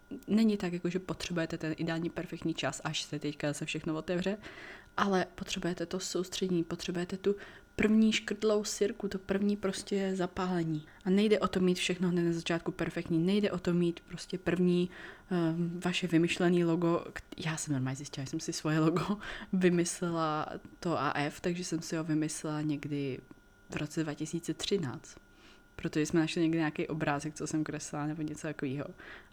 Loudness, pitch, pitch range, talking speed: -33 LUFS, 170 Hz, 155-185 Hz, 170 wpm